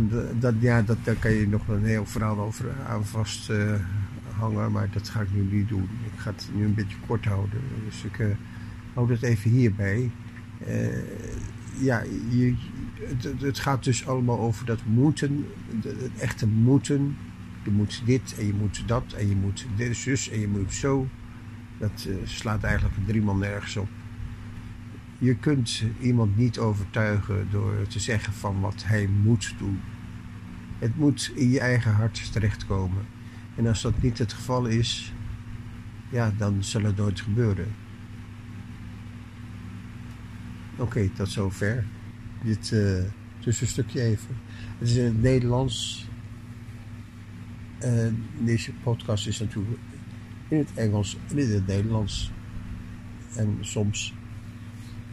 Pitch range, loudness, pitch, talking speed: 105-115 Hz, -27 LUFS, 110 Hz, 150 wpm